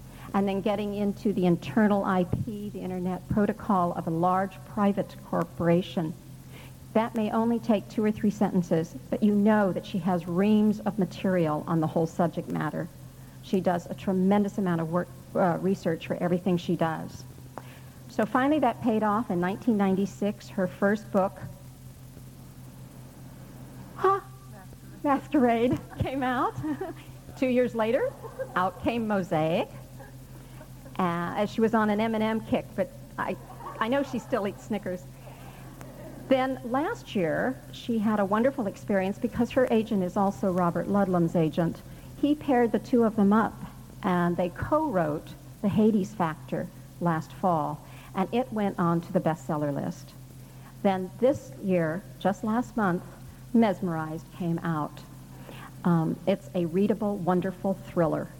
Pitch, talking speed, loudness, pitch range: 190 Hz, 145 wpm, -27 LUFS, 165-215 Hz